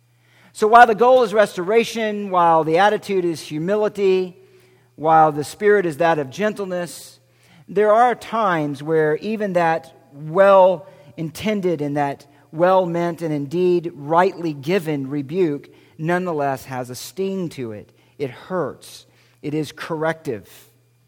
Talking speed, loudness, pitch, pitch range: 130 wpm, -19 LUFS, 165 Hz, 145-195 Hz